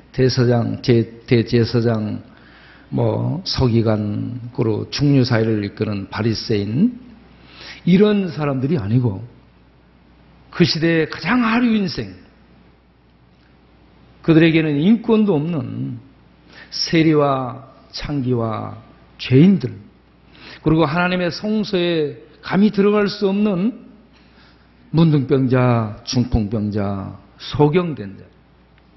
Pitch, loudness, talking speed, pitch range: 130 Hz, -18 LUFS, 195 characters per minute, 110-165 Hz